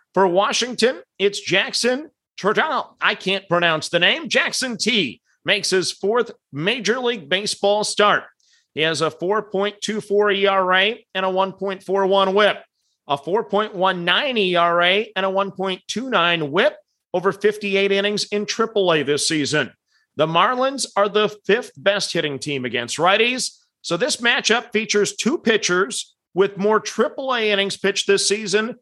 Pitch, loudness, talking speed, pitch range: 200 Hz, -19 LUFS, 135 wpm, 185-215 Hz